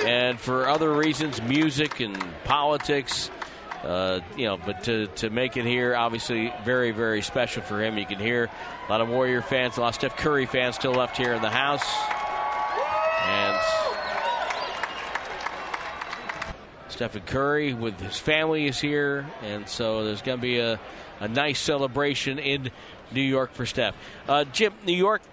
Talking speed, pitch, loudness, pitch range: 165 wpm, 130 Hz, -26 LUFS, 115-145 Hz